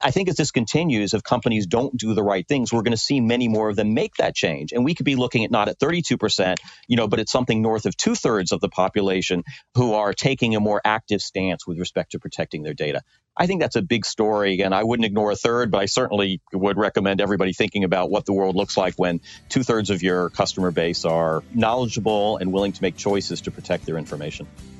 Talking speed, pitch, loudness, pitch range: 245 wpm, 105 Hz, -22 LUFS, 95-120 Hz